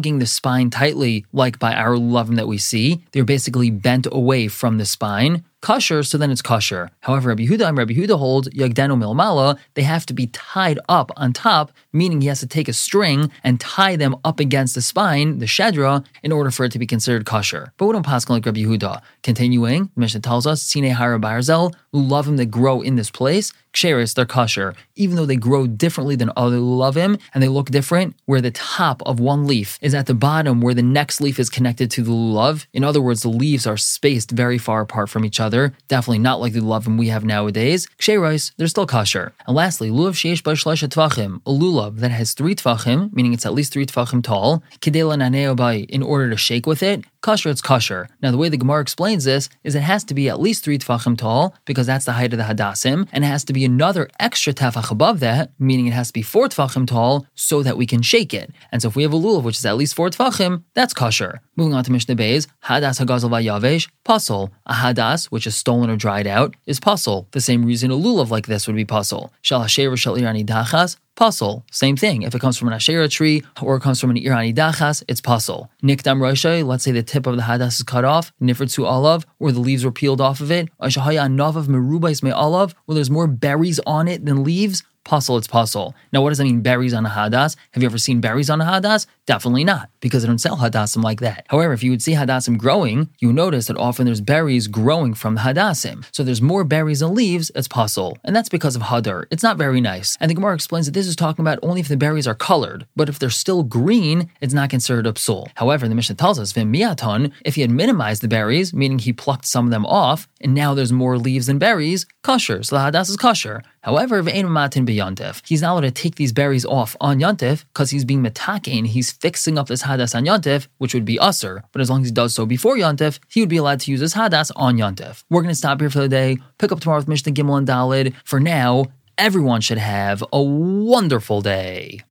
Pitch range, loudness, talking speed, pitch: 120-155 Hz, -18 LUFS, 230 wpm, 135 Hz